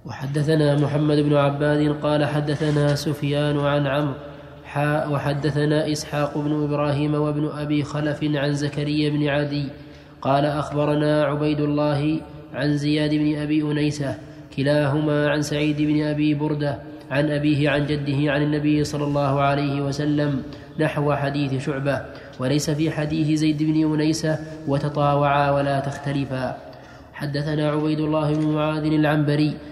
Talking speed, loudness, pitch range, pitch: 125 wpm, -22 LUFS, 145-150 Hz, 150 Hz